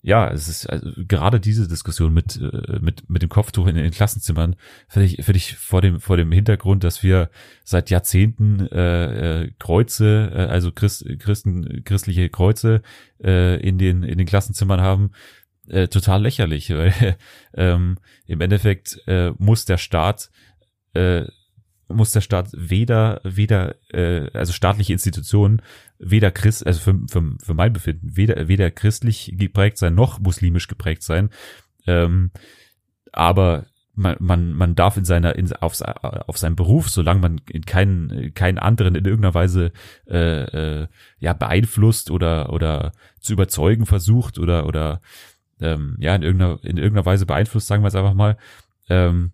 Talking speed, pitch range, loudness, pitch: 155 wpm, 85-105 Hz, -19 LUFS, 95 Hz